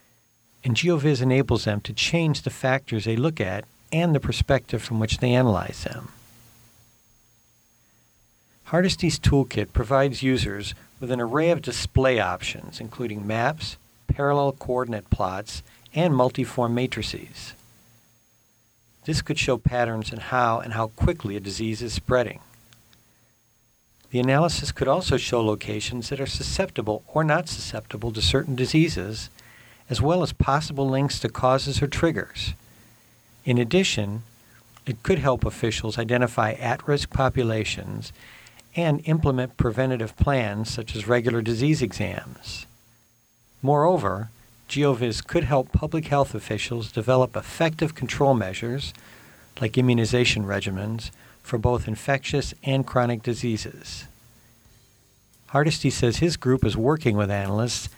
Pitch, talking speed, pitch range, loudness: 120 Hz, 125 wpm, 110-135 Hz, -24 LUFS